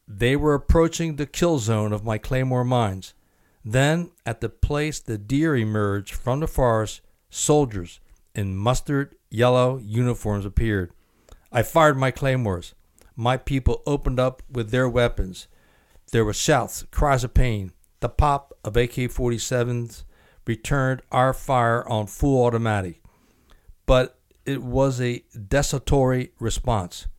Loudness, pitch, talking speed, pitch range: -23 LUFS, 120 Hz, 130 wpm, 105-135 Hz